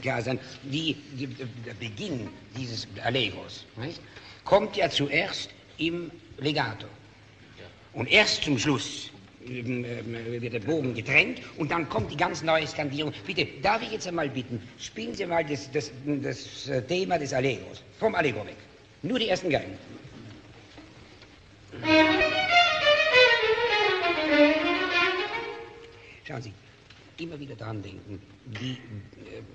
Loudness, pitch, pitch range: -26 LUFS, 135 Hz, 110-170 Hz